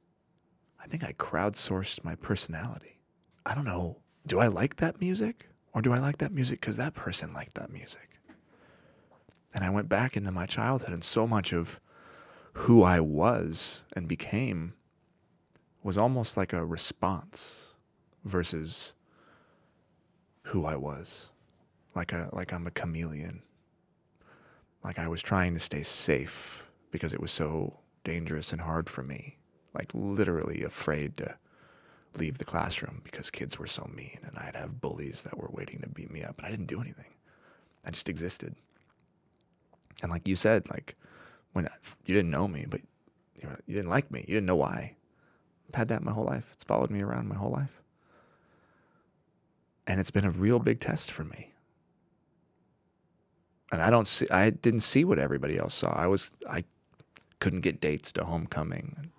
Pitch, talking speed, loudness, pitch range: 95 Hz, 170 wpm, -31 LUFS, 85-115 Hz